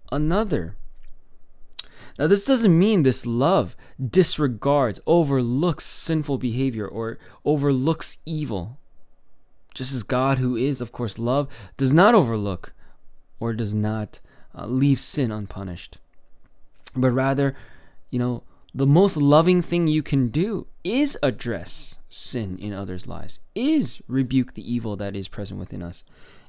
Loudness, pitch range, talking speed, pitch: -22 LUFS, 110-150 Hz, 130 wpm, 130 Hz